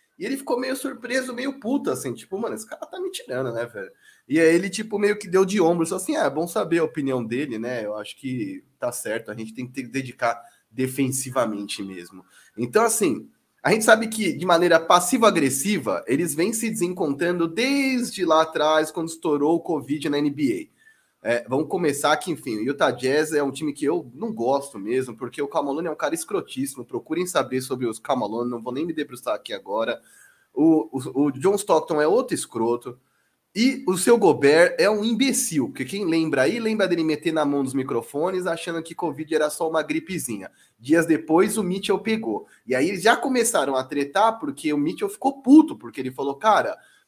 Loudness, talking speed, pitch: -23 LUFS, 205 wpm, 165 Hz